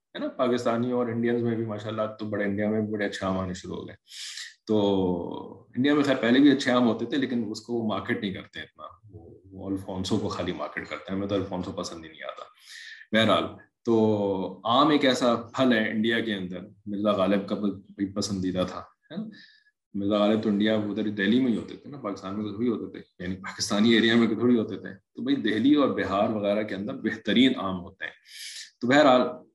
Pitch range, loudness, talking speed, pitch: 100-120 Hz, -26 LUFS, 215 wpm, 105 Hz